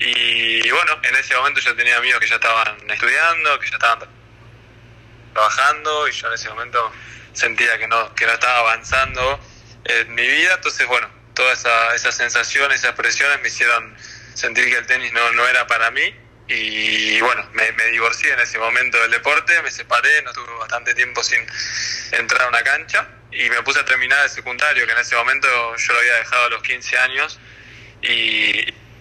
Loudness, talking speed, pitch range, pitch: -16 LUFS, 190 wpm, 115-120 Hz, 115 Hz